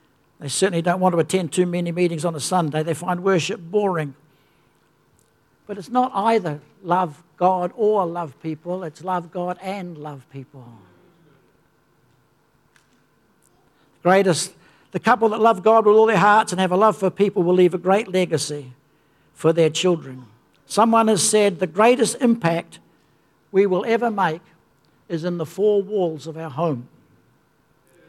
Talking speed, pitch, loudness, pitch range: 155 wpm, 180 Hz, -20 LUFS, 155-195 Hz